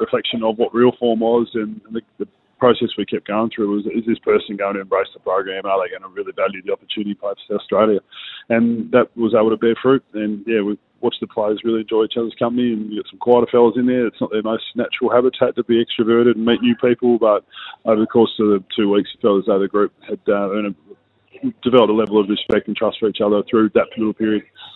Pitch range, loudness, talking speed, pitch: 105-120 Hz, -18 LUFS, 250 wpm, 115 Hz